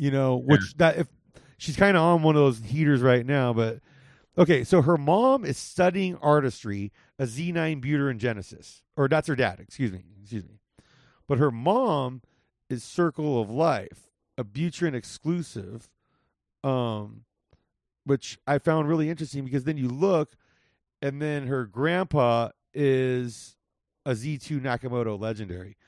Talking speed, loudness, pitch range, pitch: 155 wpm, -25 LUFS, 120-155 Hz, 140 Hz